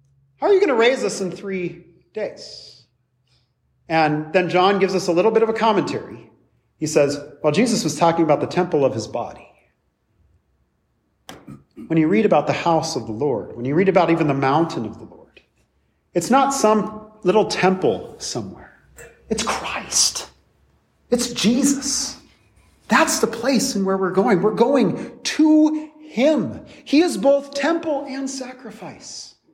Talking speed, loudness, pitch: 165 wpm, -19 LUFS, 195 Hz